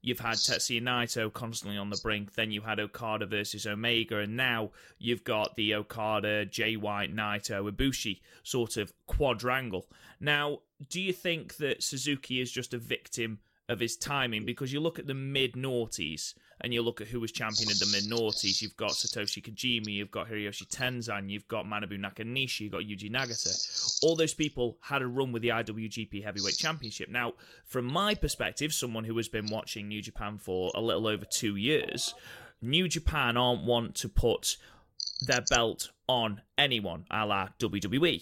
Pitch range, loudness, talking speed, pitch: 105-125 Hz, -31 LUFS, 180 wpm, 115 Hz